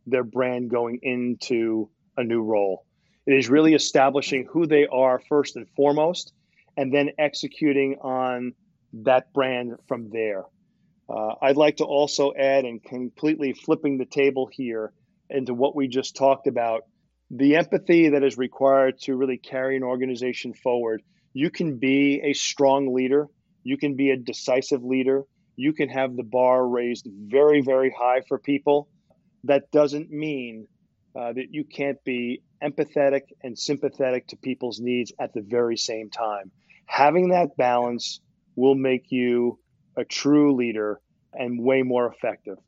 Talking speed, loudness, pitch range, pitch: 155 wpm, -23 LUFS, 125-145 Hz, 135 Hz